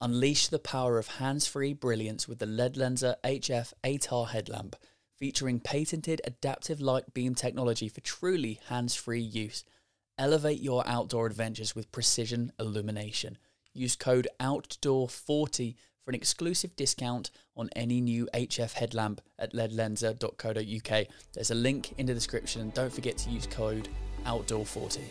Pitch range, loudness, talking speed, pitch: 110-130 Hz, -32 LUFS, 135 wpm, 120 Hz